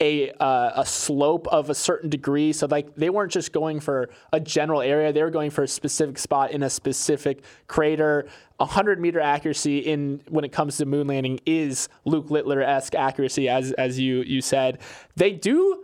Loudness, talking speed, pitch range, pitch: -23 LUFS, 195 wpm, 135-155 Hz, 145 Hz